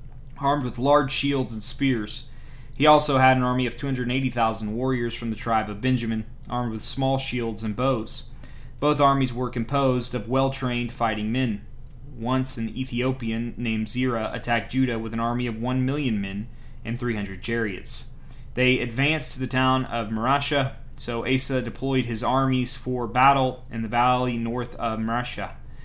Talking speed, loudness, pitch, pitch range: 175 wpm, -24 LUFS, 125 Hz, 115-130 Hz